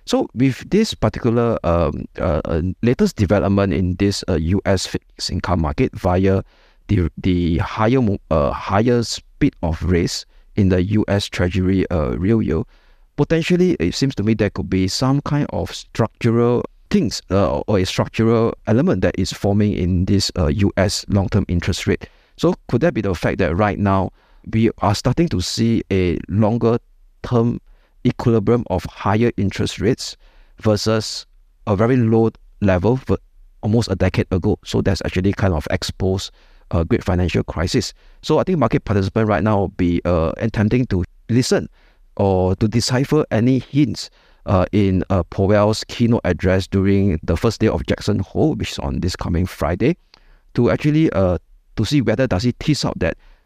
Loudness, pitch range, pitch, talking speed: -19 LUFS, 95-115 Hz, 100 Hz, 170 wpm